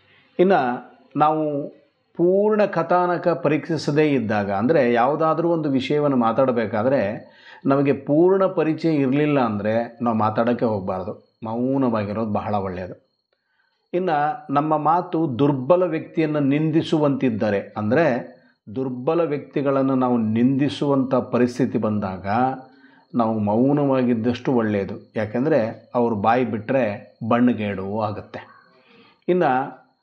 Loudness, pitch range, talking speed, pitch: -21 LUFS, 115-155 Hz, 90 wpm, 130 Hz